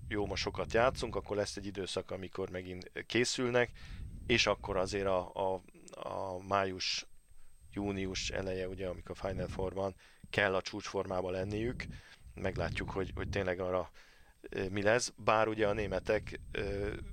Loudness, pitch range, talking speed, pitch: -35 LUFS, 90-100 Hz, 145 wpm, 95 Hz